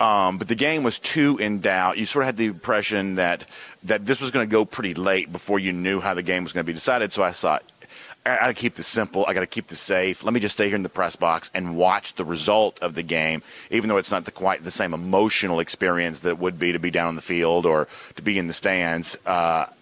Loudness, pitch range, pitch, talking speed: -23 LUFS, 85-105 Hz, 95 Hz, 280 wpm